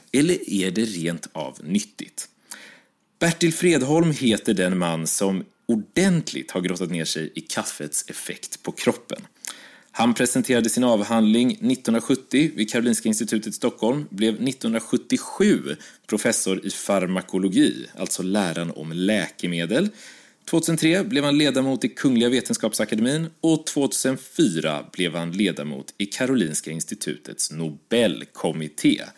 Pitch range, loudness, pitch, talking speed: 90-150 Hz, -23 LUFS, 115 Hz, 115 wpm